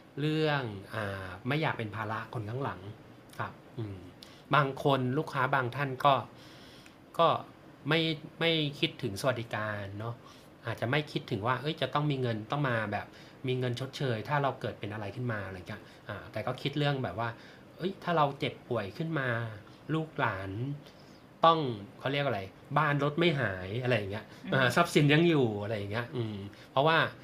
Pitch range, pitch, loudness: 110-145 Hz, 125 Hz, -31 LUFS